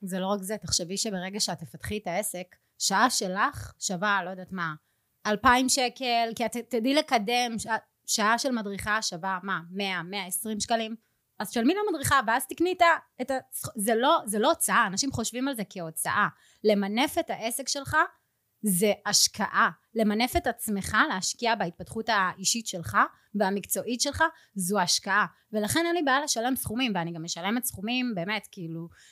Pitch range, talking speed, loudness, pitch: 190-250 Hz, 160 wpm, -27 LUFS, 220 Hz